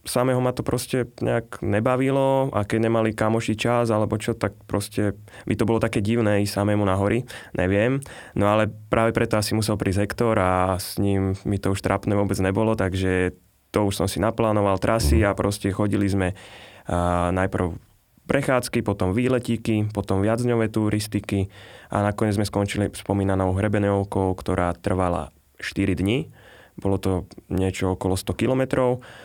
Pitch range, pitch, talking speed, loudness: 95-115 Hz, 105 Hz, 160 wpm, -23 LUFS